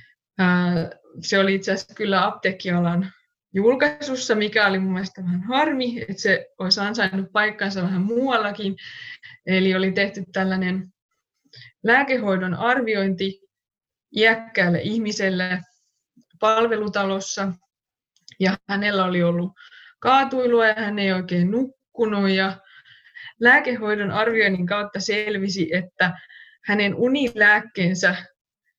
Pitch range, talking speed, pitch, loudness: 185-225 Hz, 100 wpm, 200 Hz, -21 LUFS